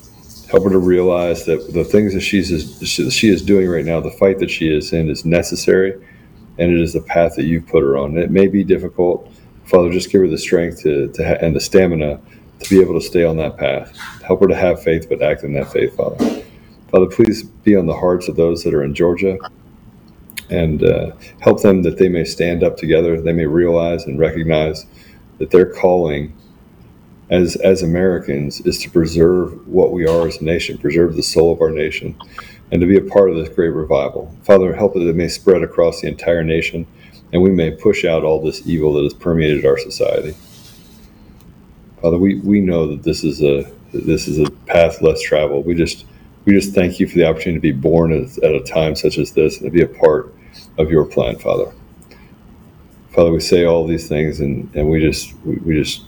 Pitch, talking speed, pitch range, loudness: 85 Hz, 220 wpm, 80-95 Hz, -15 LUFS